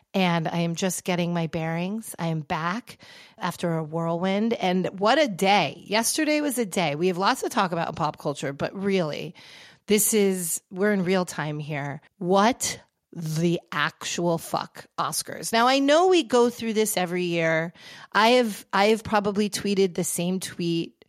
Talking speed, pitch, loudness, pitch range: 175 wpm, 185 Hz, -24 LUFS, 170-210 Hz